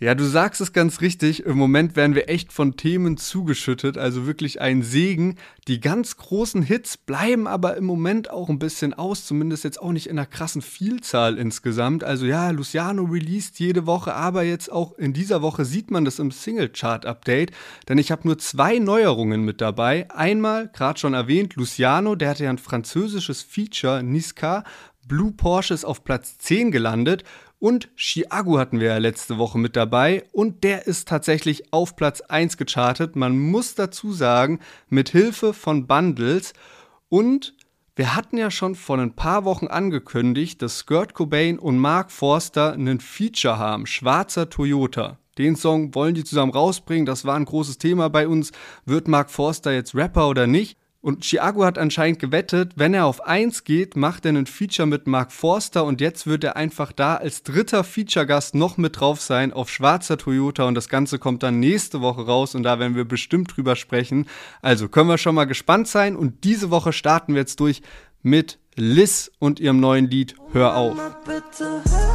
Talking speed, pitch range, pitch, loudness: 180 wpm, 135-180 Hz, 155 Hz, -21 LUFS